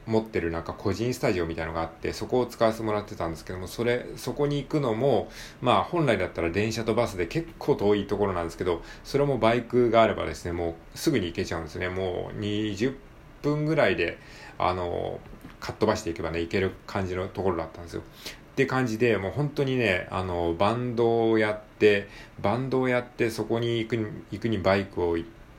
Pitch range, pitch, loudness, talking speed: 90-120 Hz, 110 Hz, -27 LUFS, 420 characters per minute